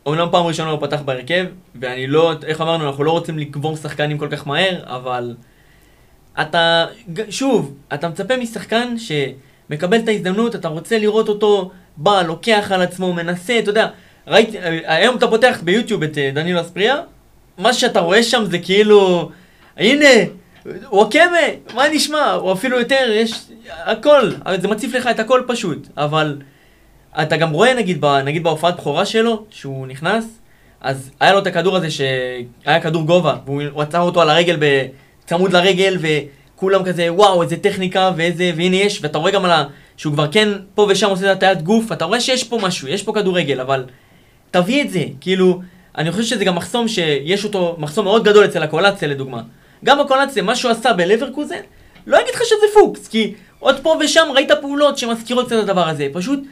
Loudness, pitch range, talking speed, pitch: -16 LUFS, 155-220 Hz, 180 wpm, 185 Hz